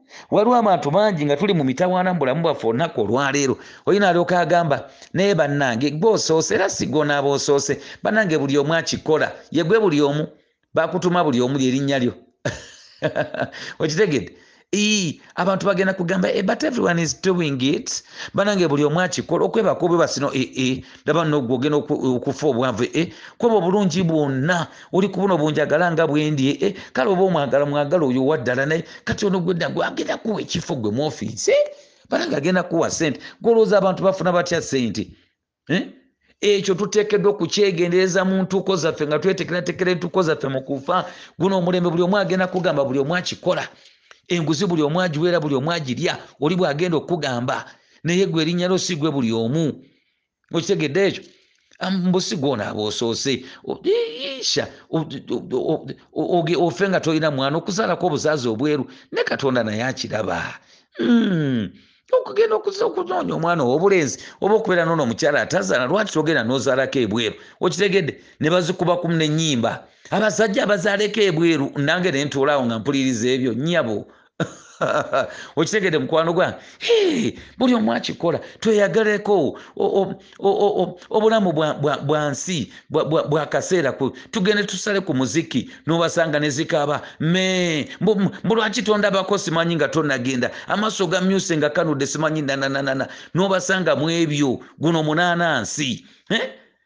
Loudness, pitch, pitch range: -20 LUFS, 170 Hz, 145-190 Hz